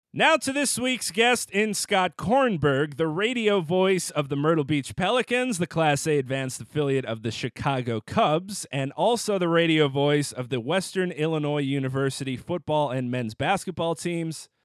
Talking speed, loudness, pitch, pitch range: 165 wpm, -25 LUFS, 160 Hz, 140-195 Hz